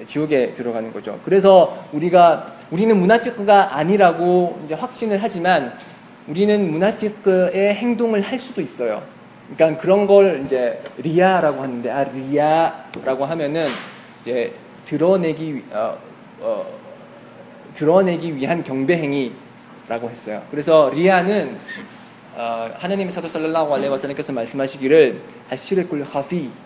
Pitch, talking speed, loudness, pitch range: 170 Hz, 295 characters per minute, -18 LUFS, 140-200 Hz